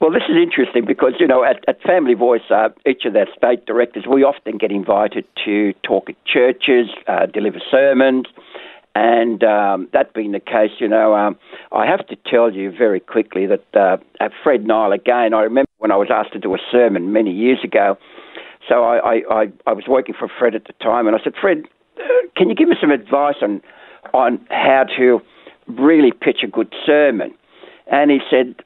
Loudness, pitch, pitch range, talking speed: -16 LUFS, 125 Hz, 110-145 Hz, 205 wpm